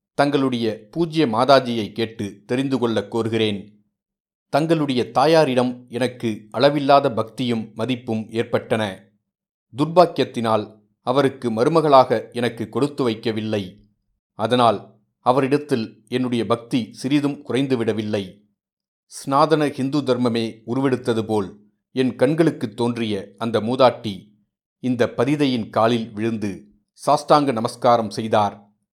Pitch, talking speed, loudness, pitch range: 120 Hz, 90 wpm, -20 LUFS, 110-135 Hz